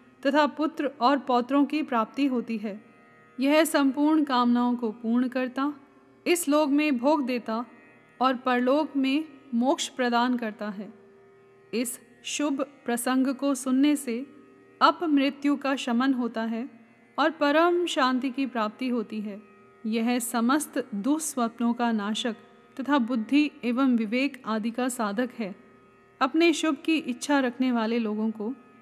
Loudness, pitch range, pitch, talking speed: -26 LUFS, 235-285 Hz, 255 Hz, 135 wpm